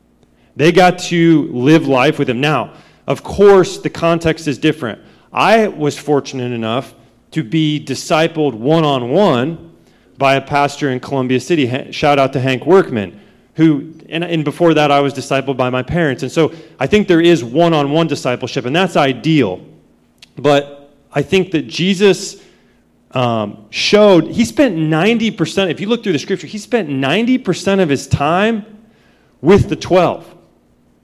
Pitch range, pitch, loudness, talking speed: 135-175 Hz, 150 Hz, -14 LUFS, 160 wpm